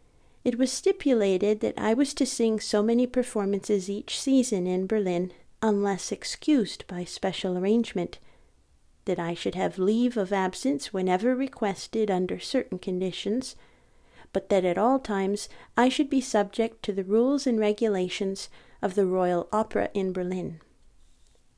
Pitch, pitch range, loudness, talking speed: 205 Hz, 185-235 Hz, -27 LUFS, 145 wpm